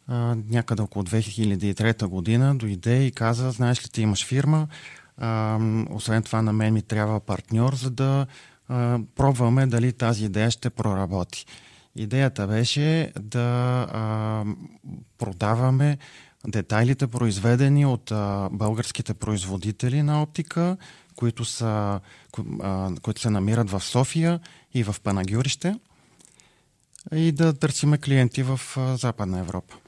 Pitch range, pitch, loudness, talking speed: 110-135 Hz, 120 Hz, -24 LUFS, 110 wpm